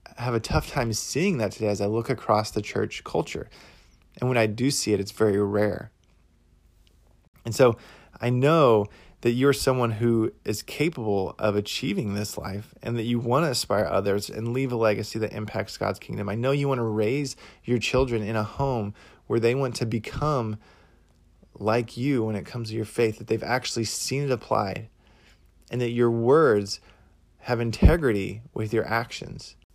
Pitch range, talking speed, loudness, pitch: 105-120 Hz, 185 wpm, -25 LUFS, 110 Hz